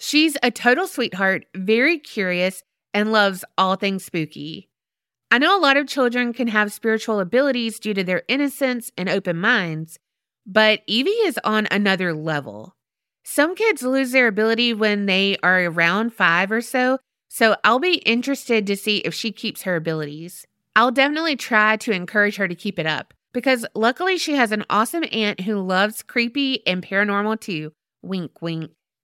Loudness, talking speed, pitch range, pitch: -20 LUFS, 170 wpm, 190-250 Hz, 215 Hz